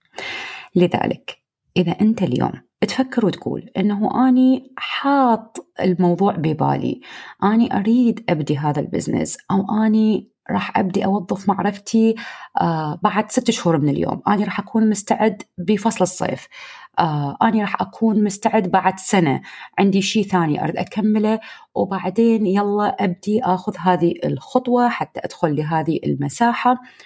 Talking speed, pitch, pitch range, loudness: 120 wpm, 205 Hz, 180-225 Hz, -19 LUFS